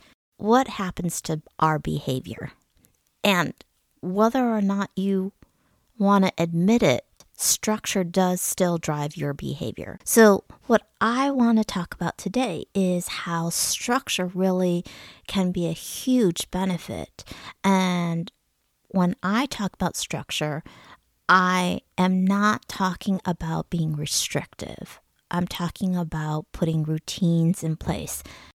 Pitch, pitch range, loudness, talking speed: 185 Hz, 170-200 Hz, -24 LUFS, 120 wpm